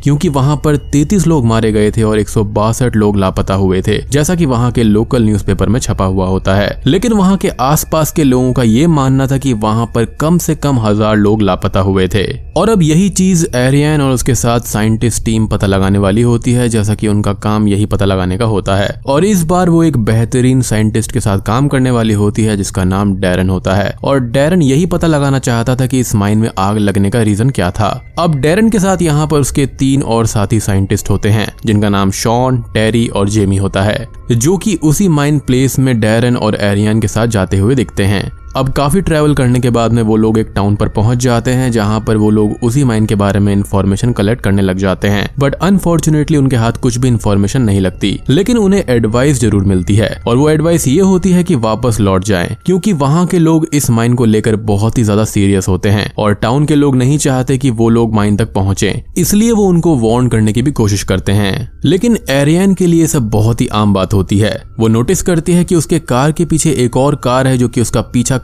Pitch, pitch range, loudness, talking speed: 115 Hz, 105-145 Hz, -12 LUFS, 225 wpm